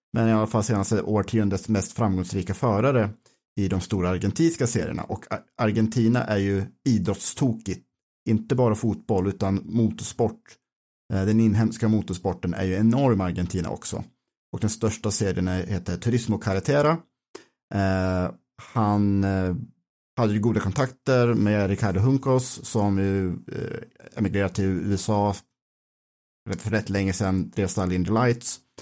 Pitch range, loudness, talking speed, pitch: 95-115 Hz, -24 LUFS, 125 wpm, 105 Hz